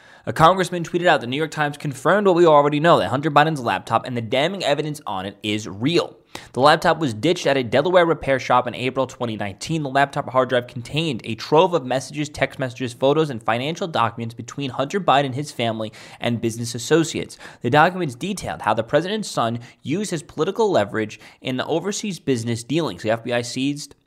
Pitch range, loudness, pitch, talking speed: 120-155 Hz, -21 LUFS, 135 Hz, 195 wpm